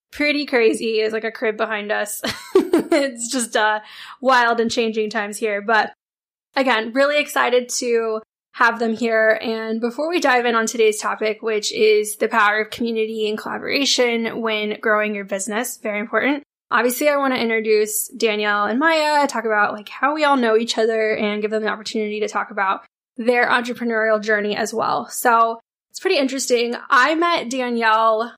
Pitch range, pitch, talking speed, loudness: 220-255 Hz, 225 Hz, 175 wpm, -19 LUFS